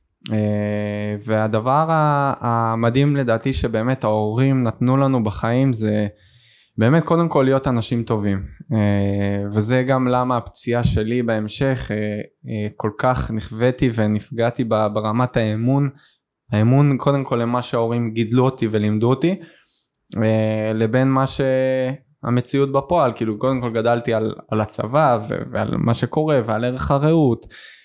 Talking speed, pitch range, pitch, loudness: 110 wpm, 110-130 Hz, 120 Hz, -20 LUFS